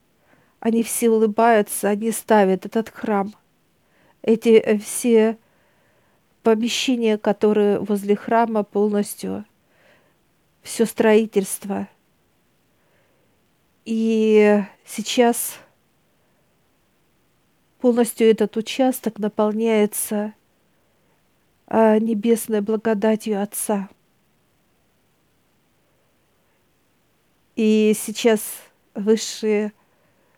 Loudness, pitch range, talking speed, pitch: -20 LUFS, 210-225 Hz, 55 wpm, 220 Hz